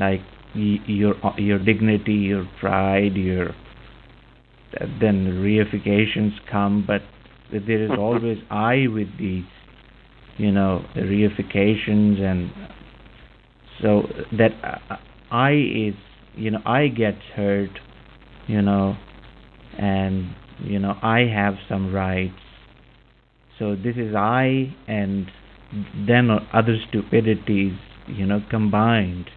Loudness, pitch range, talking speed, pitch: -21 LUFS, 100-110 Hz, 110 wpm, 105 Hz